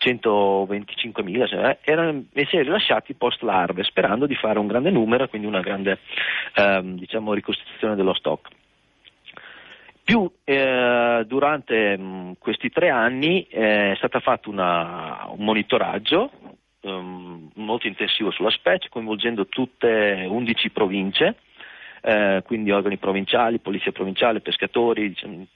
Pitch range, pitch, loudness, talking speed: 95-120 Hz, 105 Hz, -21 LUFS, 120 wpm